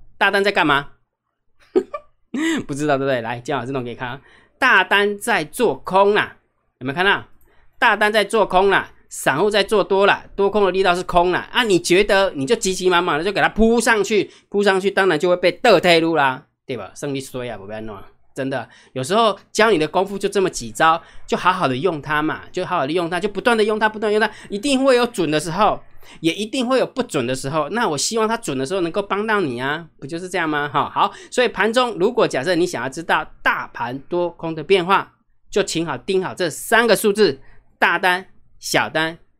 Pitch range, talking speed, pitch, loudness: 155-210 Hz, 310 characters per minute, 185 Hz, -18 LUFS